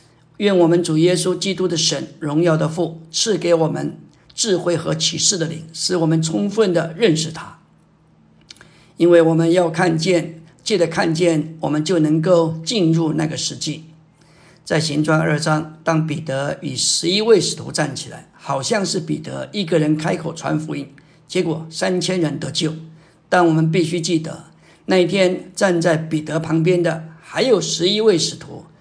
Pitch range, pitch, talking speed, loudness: 155-175 Hz, 165 Hz, 245 characters per minute, -18 LUFS